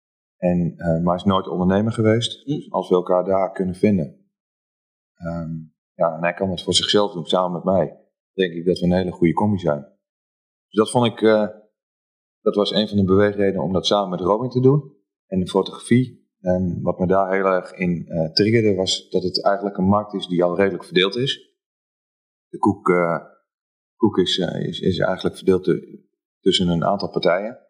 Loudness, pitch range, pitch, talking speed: -20 LUFS, 90-105 Hz, 95 Hz, 205 wpm